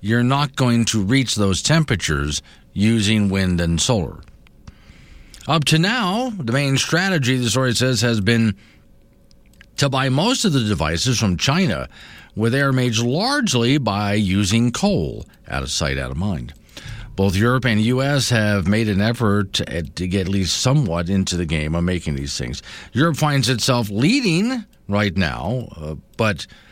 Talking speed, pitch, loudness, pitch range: 160 wpm, 110 Hz, -19 LUFS, 95-130 Hz